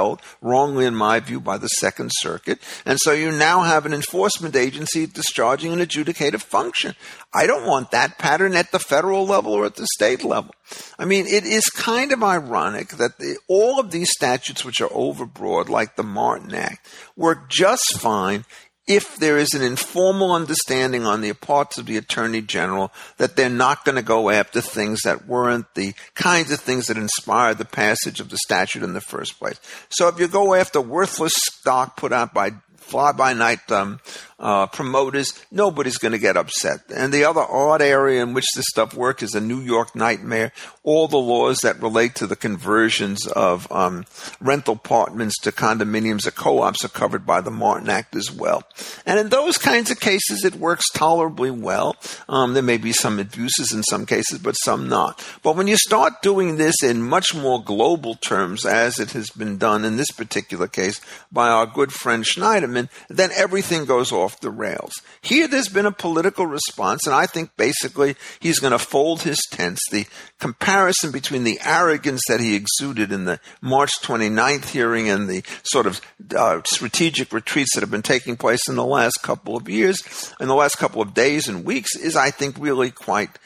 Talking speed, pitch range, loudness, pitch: 195 wpm, 115-170 Hz, -20 LUFS, 135 Hz